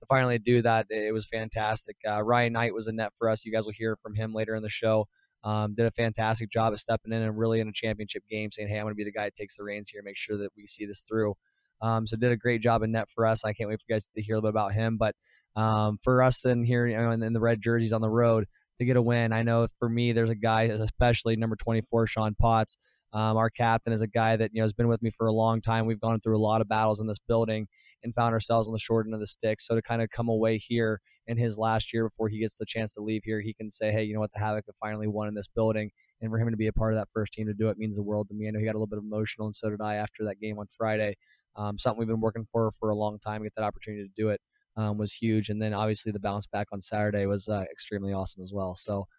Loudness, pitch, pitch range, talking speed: -29 LUFS, 110 Hz, 105-115 Hz, 310 wpm